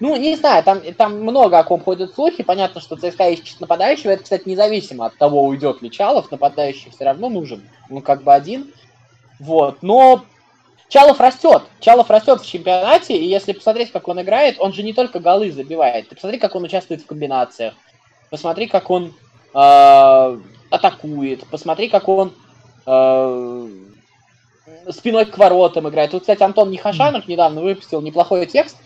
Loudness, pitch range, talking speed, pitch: -14 LUFS, 140-210 Hz, 160 wpm, 175 Hz